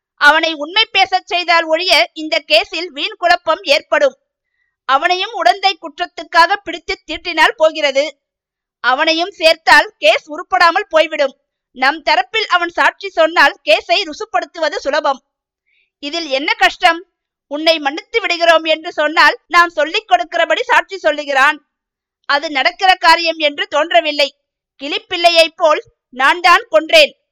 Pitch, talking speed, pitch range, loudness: 325 Hz, 115 wpm, 295-355 Hz, -13 LUFS